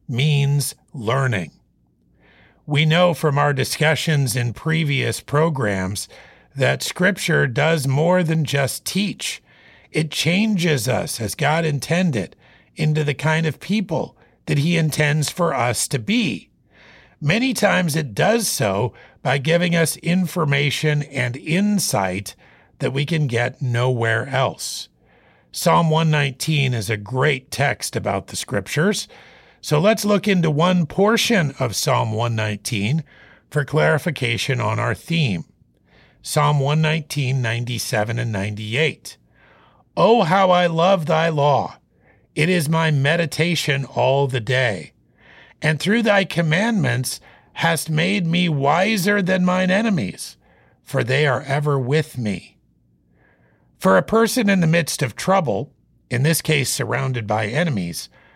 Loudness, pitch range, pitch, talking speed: -19 LUFS, 125-170 Hz, 150 Hz, 125 wpm